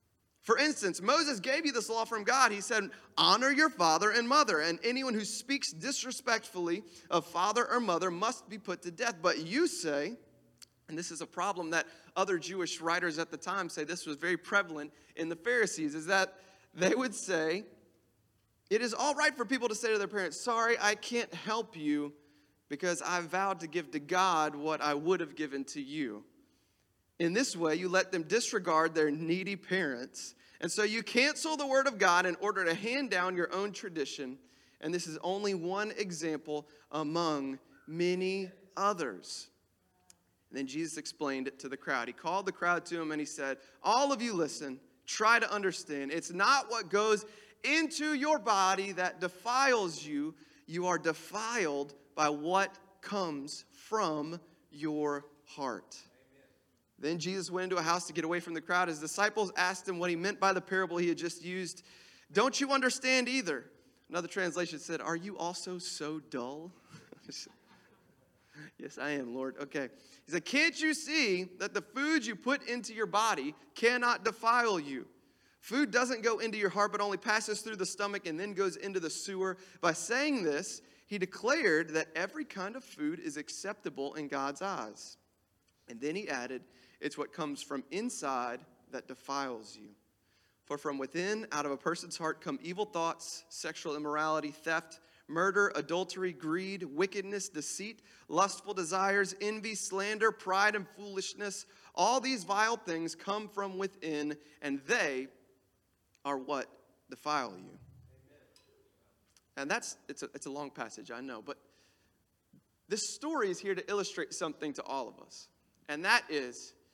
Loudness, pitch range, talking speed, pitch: -33 LUFS, 155-215 Hz, 170 wpm, 180 Hz